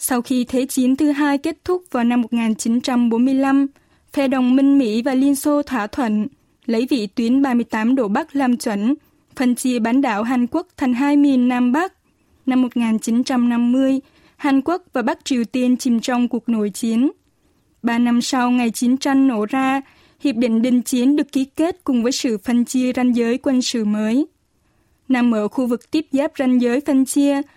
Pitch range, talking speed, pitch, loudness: 240-275 Hz, 190 wpm, 255 Hz, -18 LUFS